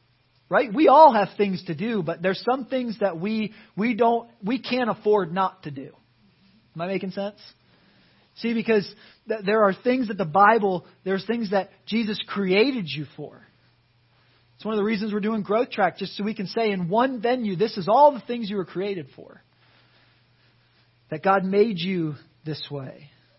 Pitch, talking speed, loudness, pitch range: 200 Hz, 185 wpm, -23 LUFS, 180-220 Hz